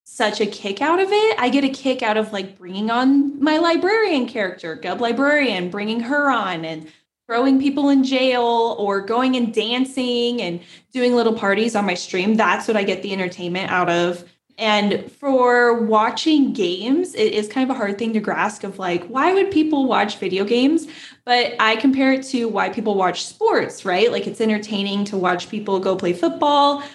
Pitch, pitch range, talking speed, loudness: 230 Hz, 200-270 Hz, 195 wpm, -19 LUFS